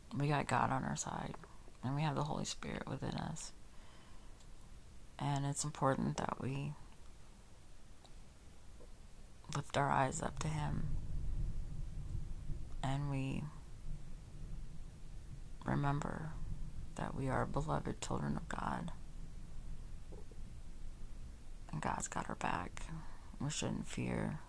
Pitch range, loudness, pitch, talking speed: 85-145 Hz, -41 LUFS, 125 Hz, 105 wpm